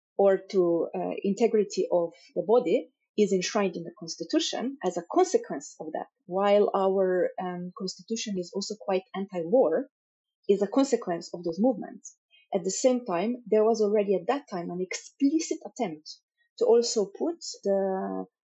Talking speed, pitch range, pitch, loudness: 155 wpm, 185-250 Hz, 200 Hz, -27 LUFS